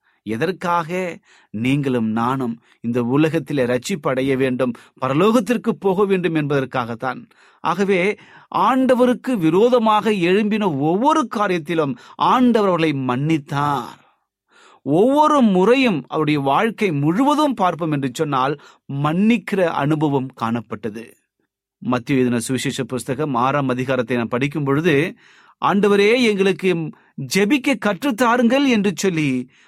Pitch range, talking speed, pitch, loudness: 135-210 Hz, 85 wpm, 160 Hz, -18 LUFS